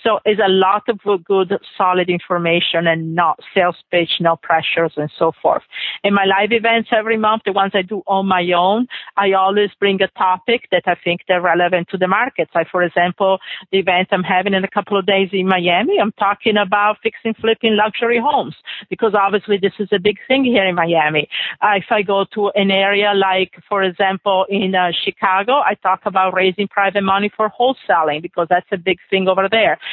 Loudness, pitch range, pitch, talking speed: -16 LUFS, 180-205 Hz, 195 Hz, 205 wpm